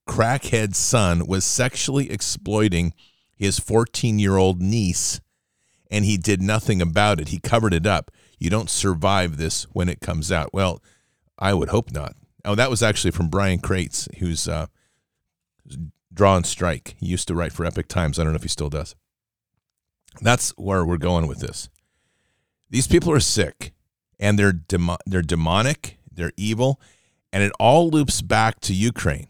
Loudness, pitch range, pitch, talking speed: -21 LUFS, 85-110 Hz, 95 Hz, 165 wpm